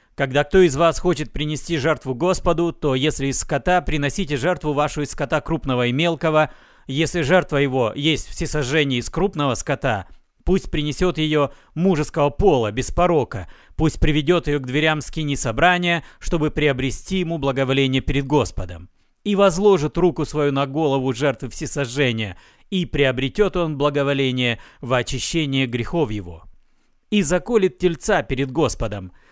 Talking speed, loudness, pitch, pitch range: 140 wpm, -20 LUFS, 150 Hz, 135-165 Hz